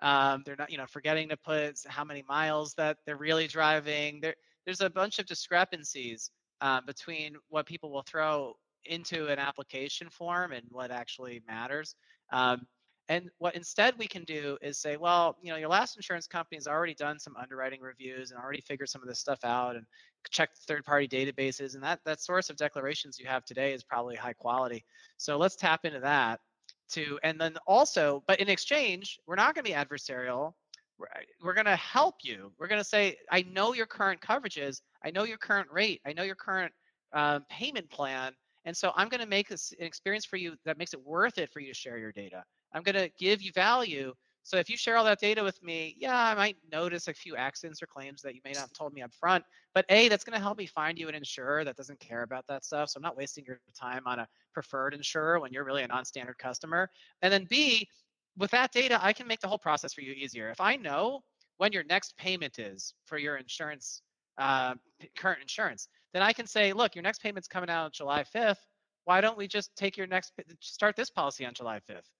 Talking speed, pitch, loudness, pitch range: 225 wpm, 155 Hz, -31 LUFS, 135-190 Hz